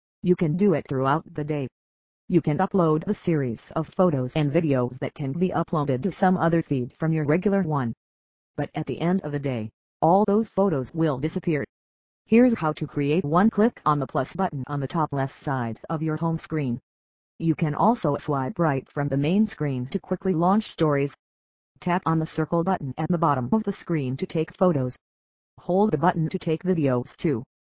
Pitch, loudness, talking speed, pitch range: 155 Hz, -24 LUFS, 200 wpm, 135-175 Hz